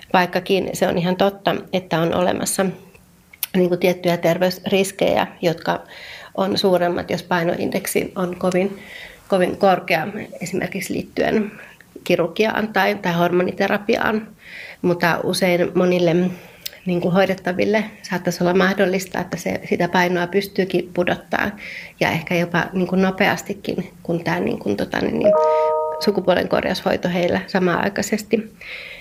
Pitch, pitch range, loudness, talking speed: 185 Hz, 175-195 Hz, -20 LUFS, 120 wpm